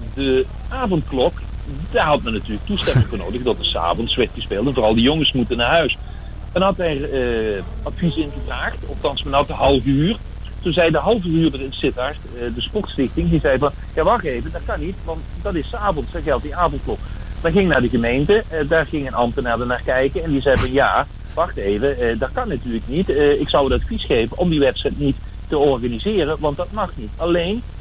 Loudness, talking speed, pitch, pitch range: -19 LUFS, 210 wpm, 145 Hz, 125-165 Hz